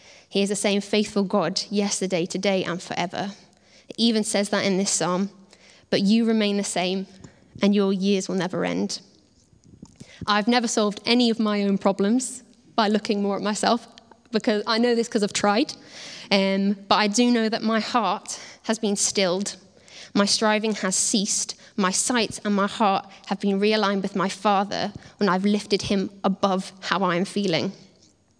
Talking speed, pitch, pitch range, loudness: 175 wpm, 205 Hz, 195-220 Hz, -23 LUFS